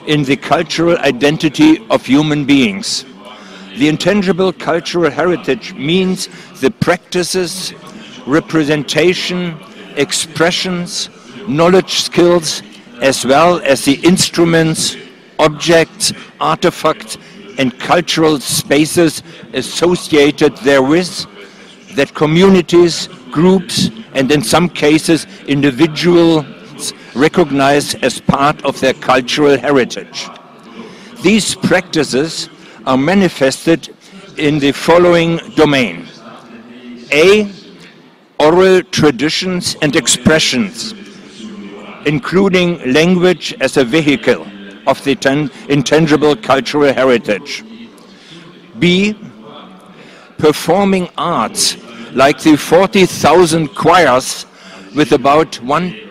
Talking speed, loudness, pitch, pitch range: 85 wpm, -12 LUFS, 165 Hz, 145-185 Hz